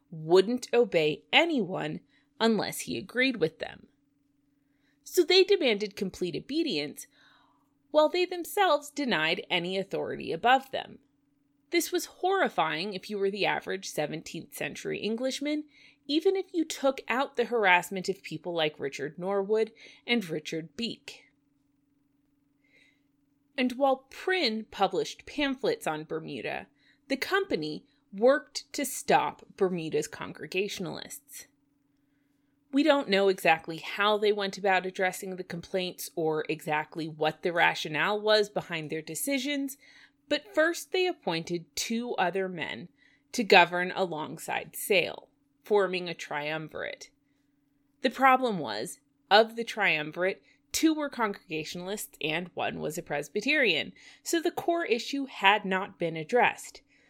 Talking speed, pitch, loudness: 120 wpm, 200 Hz, -28 LUFS